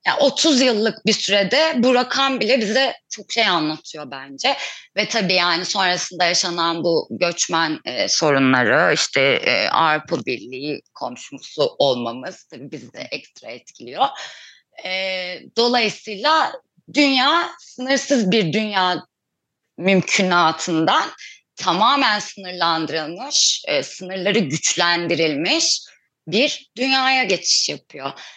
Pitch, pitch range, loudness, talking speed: 195 Hz, 170-255 Hz, -18 LUFS, 105 wpm